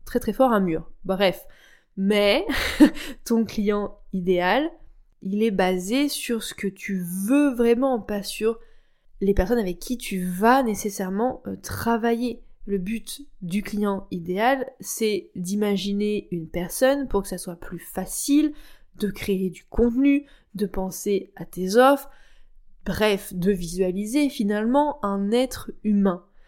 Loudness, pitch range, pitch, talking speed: -24 LUFS, 190-250 Hz, 210 Hz, 135 wpm